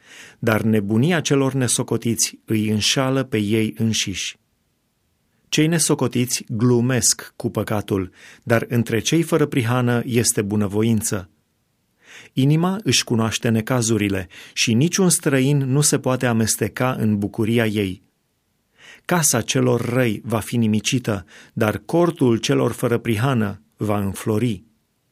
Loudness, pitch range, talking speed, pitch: -20 LUFS, 110-130 Hz, 115 wpm, 115 Hz